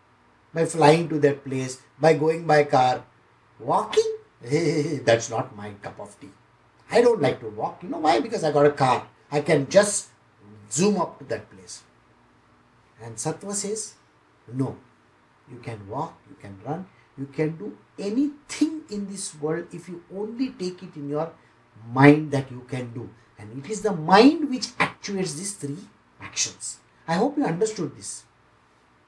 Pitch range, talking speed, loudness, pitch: 120-185 Hz, 165 wpm, -24 LUFS, 150 Hz